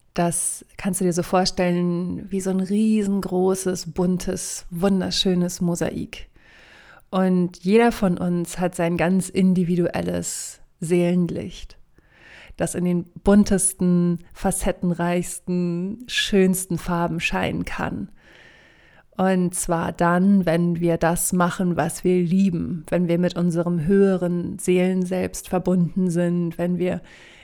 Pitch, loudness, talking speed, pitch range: 180 Hz, -22 LUFS, 110 wpm, 175-190 Hz